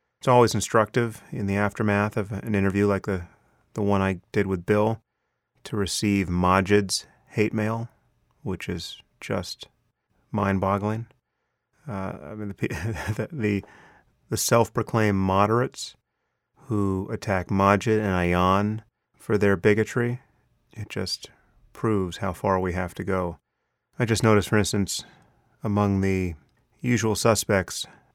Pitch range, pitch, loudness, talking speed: 95-110 Hz, 105 Hz, -25 LUFS, 130 wpm